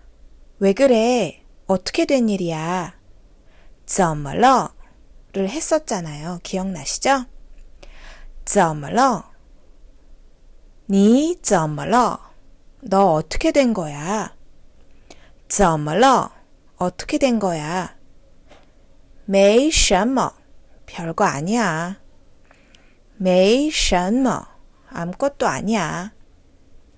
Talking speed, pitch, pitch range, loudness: 145 characters per minute, 190 Hz, 160-235 Hz, -19 LUFS